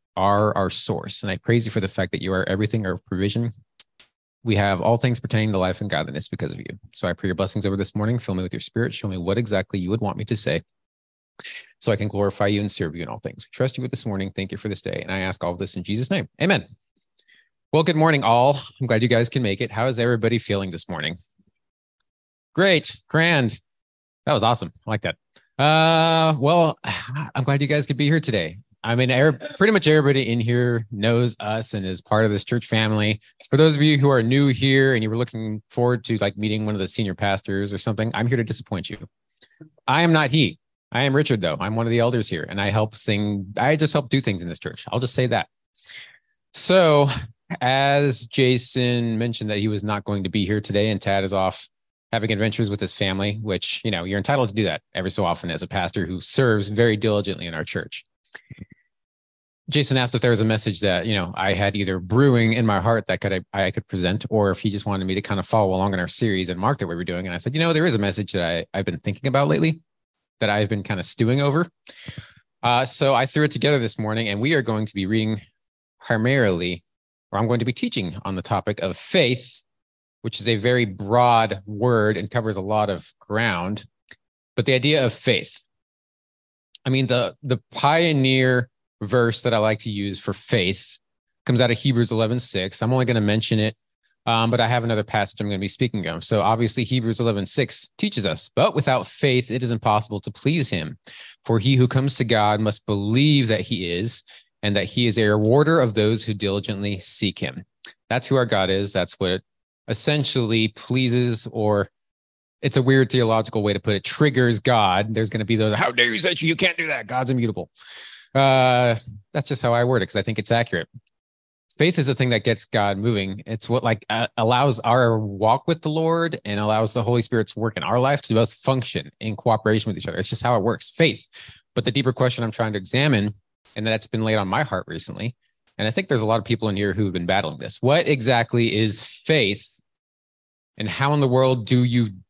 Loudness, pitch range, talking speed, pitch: -21 LUFS, 100-125 Hz, 230 wpm, 110 Hz